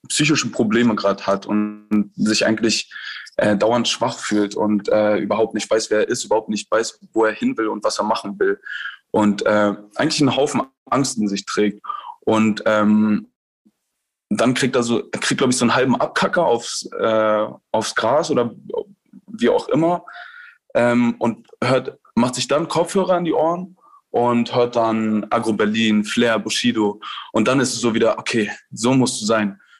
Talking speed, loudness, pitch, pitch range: 175 wpm, -19 LUFS, 115 Hz, 105-150 Hz